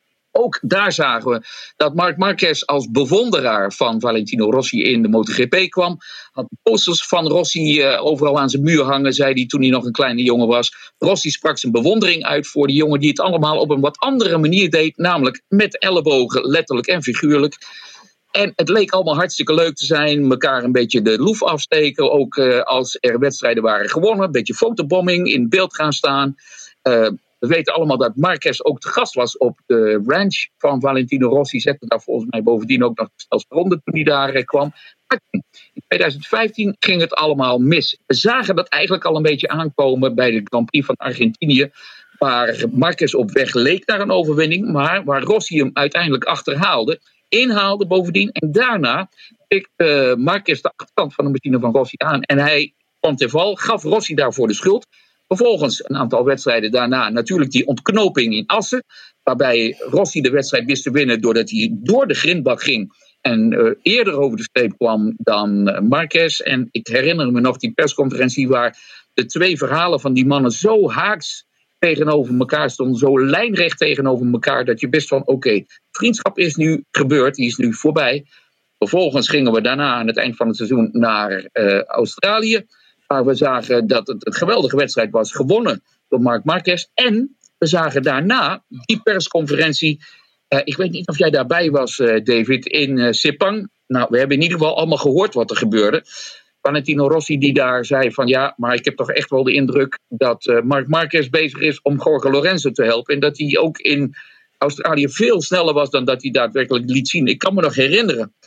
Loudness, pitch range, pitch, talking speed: -16 LUFS, 130-180 Hz, 145 Hz, 190 wpm